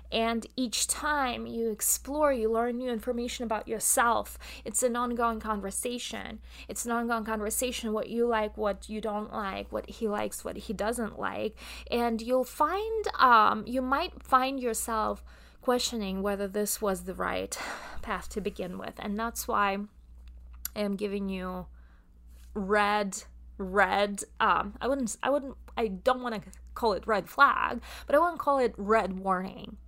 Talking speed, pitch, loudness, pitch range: 160 wpm, 225 Hz, -29 LUFS, 205-245 Hz